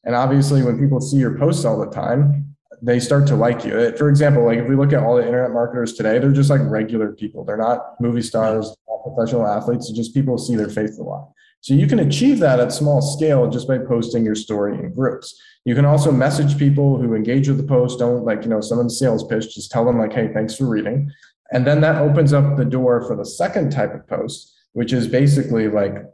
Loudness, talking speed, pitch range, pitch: -18 LUFS, 240 wpm, 115-140 Hz, 125 Hz